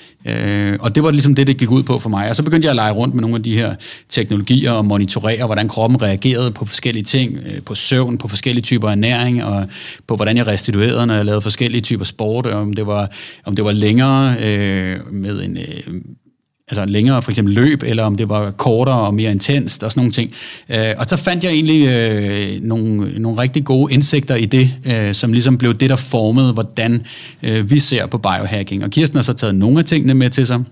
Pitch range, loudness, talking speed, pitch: 105-130 Hz, -15 LUFS, 225 wpm, 115 Hz